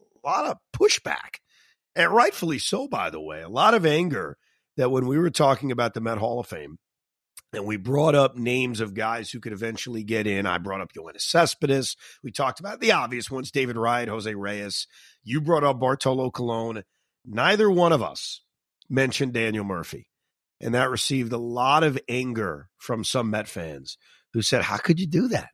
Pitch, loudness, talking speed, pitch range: 125 Hz, -24 LUFS, 195 wpm, 110-140 Hz